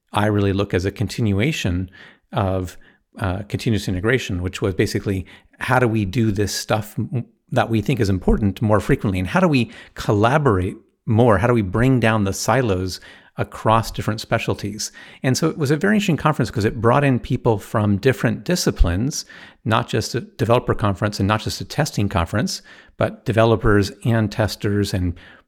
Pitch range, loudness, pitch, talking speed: 100-125 Hz, -20 LUFS, 110 Hz, 175 wpm